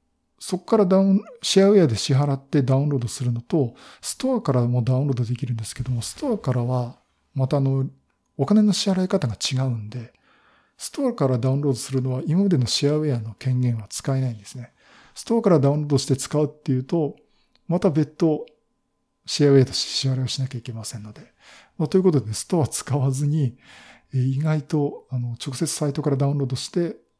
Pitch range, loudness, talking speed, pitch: 125-155 Hz, -22 LUFS, 415 characters per minute, 140 Hz